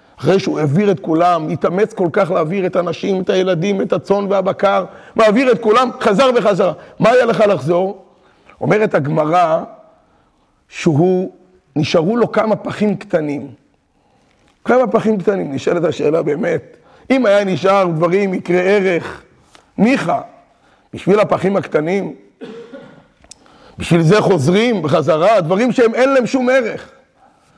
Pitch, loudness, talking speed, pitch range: 195 Hz, -15 LUFS, 130 wpm, 180-220 Hz